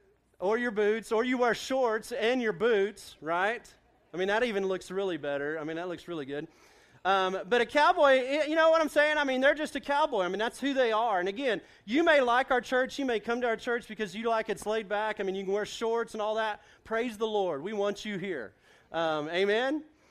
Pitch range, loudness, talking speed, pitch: 195-260 Hz, -29 LUFS, 245 wpm, 225 Hz